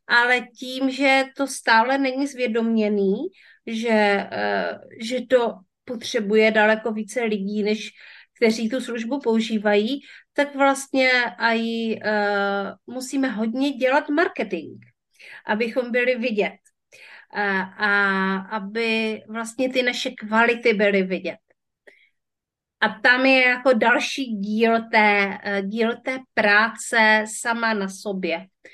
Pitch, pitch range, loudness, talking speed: 230 Hz, 210-255 Hz, -21 LUFS, 105 wpm